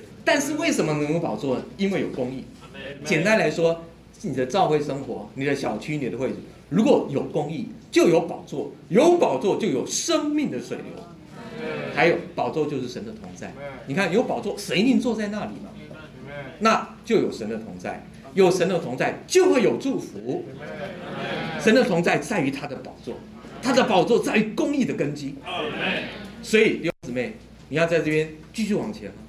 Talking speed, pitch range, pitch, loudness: 255 characters per minute, 145-225 Hz, 170 Hz, -23 LUFS